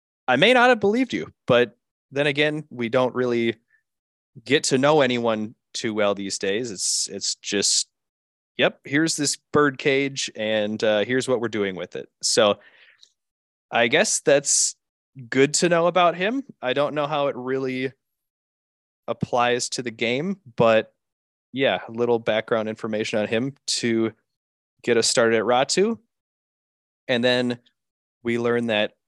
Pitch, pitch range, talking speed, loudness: 125 Hz, 110-145 Hz, 155 wpm, -22 LUFS